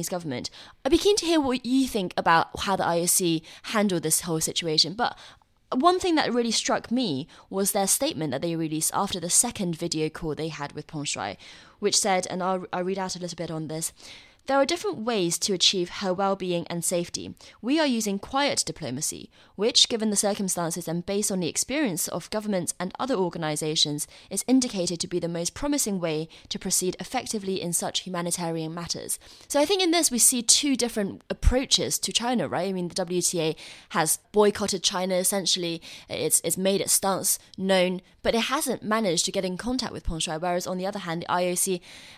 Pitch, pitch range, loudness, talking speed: 185 Hz, 170-215 Hz, -25 LUFS, 200 wpm